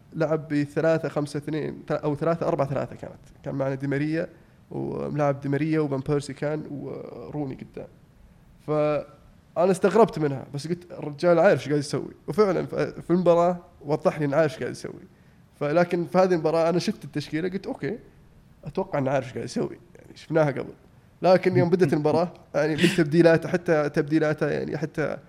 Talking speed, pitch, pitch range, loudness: 155 wpm, 155 Hz, 145-170 Hz, -25 LUFS